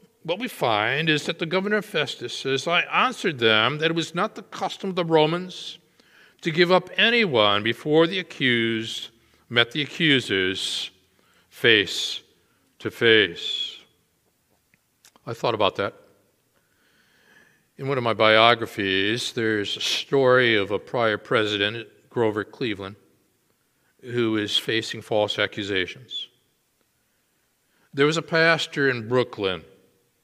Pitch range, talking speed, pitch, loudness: 110-165 Hz, 125 wpm, 130 Hz, -22 LUFS